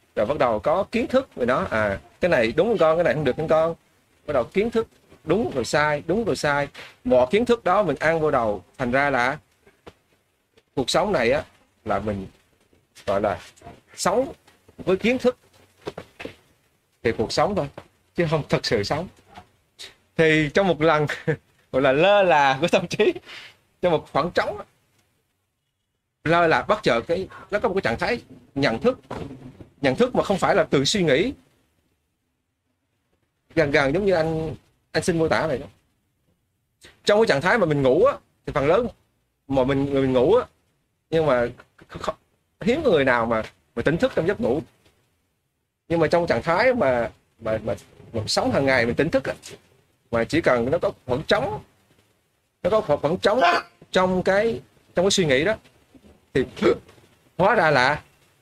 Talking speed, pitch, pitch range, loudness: 185 wpm, 150 Hz, 125-180 Hz, -22 LUFS